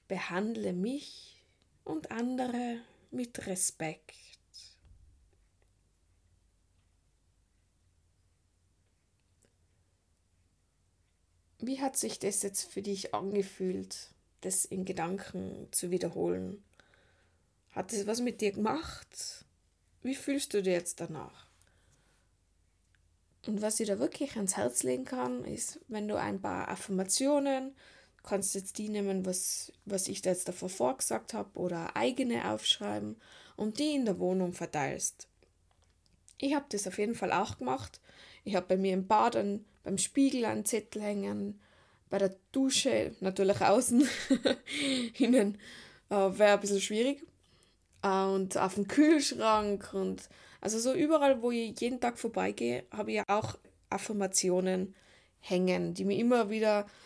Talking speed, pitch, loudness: 125 wpm, 190 Hz, -32 LUFS